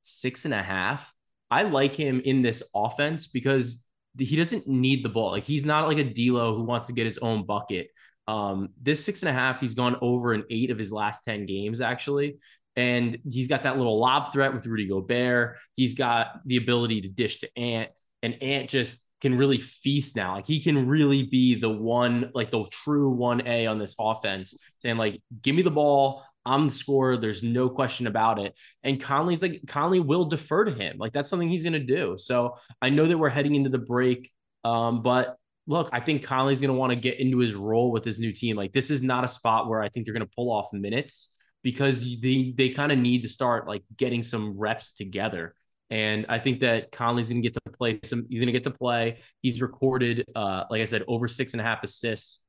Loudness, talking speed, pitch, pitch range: -26 LUFS, 230 wpm, 125 Hz, 115-135 Hz